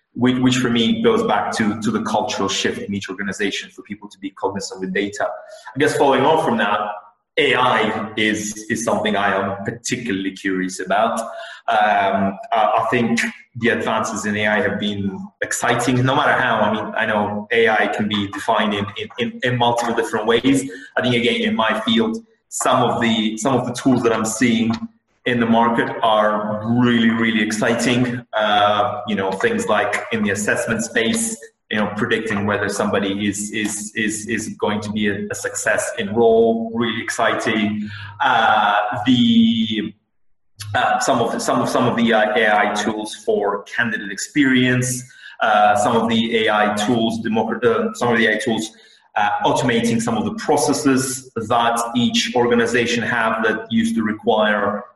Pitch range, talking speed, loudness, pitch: 105-125 Hz, 170 wpm, -18 LUFS, 115 Hz